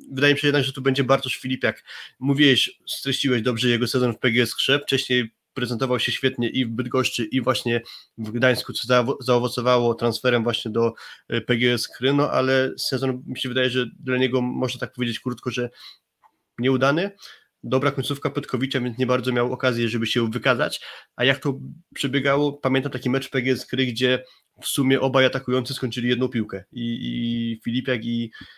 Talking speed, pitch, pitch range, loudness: 170 wpm, 130 Hz, 120-135 Hz, -22 LUFS